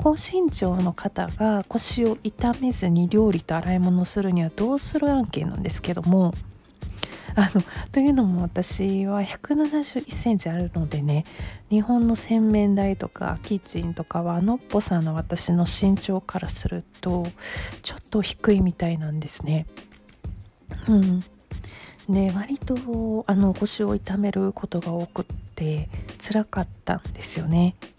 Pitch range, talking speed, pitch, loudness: 170-215 Hz, 270 characters per minute, 195 Hz, -24 LUFS